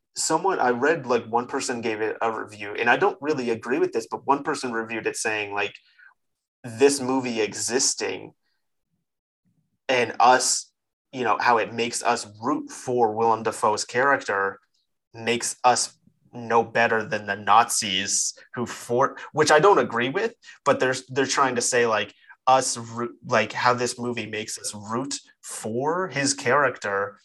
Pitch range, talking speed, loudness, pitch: 110-130 Hz, 160 wpm, -23 LUFS, 120 Hz